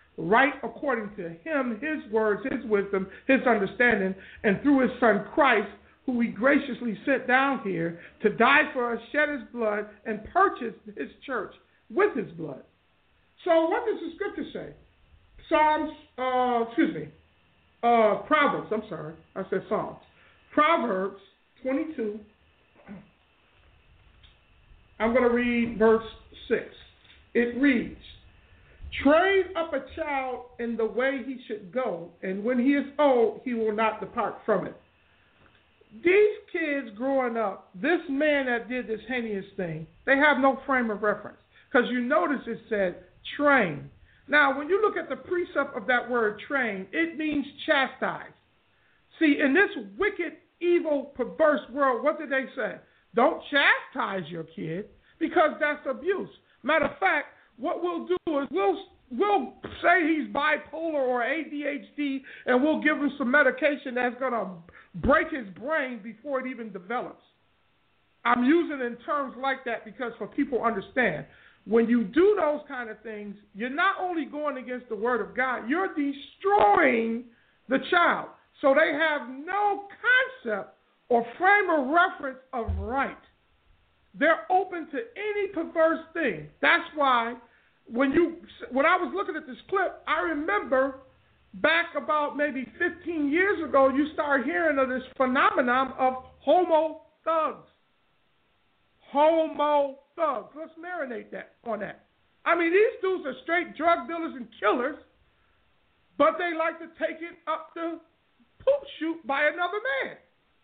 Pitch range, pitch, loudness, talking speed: 235-320 Hz, 275 Hz, -26 LUFS, 150 wpm